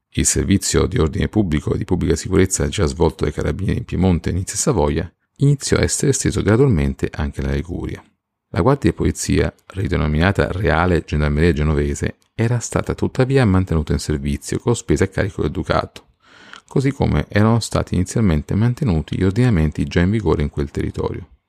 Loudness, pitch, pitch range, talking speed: -19 LUFS, 90 Hz, 75-105 Hz, 170 wpm